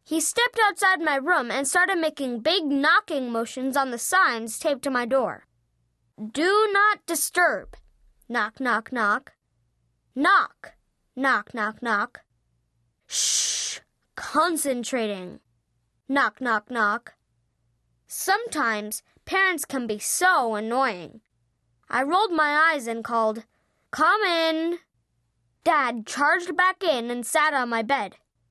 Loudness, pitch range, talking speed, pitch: -23 LUFS, 210-320 Hz, 120 wpm, 250 Hz